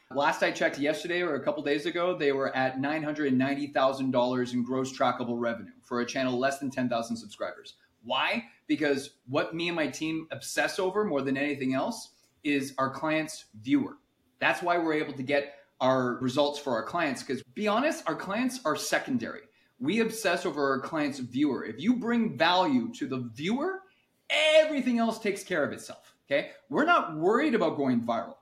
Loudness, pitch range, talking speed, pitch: -29 LUFS, 135-215 Hz, 180 wpm, 150 Hz